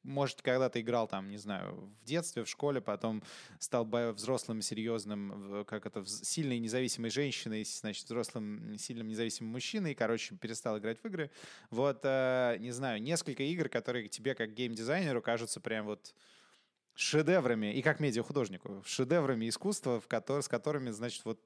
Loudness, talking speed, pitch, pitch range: -36 LUFS, 155 wpm, 120 Hz, 110-140 Hz